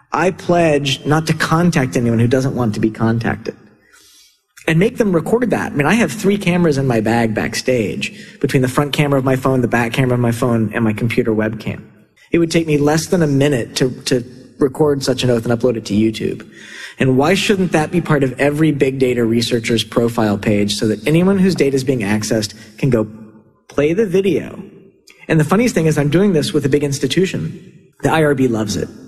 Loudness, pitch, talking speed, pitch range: -16 LUFS, 140 Hz, 215 wpm, 120-165 Hz